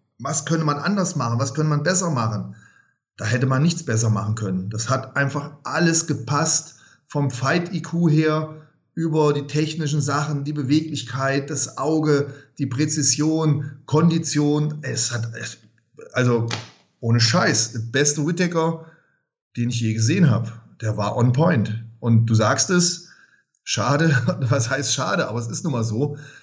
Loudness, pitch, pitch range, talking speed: -21 LUFS, 145 Hz, 120-155 Hz, 150 wpm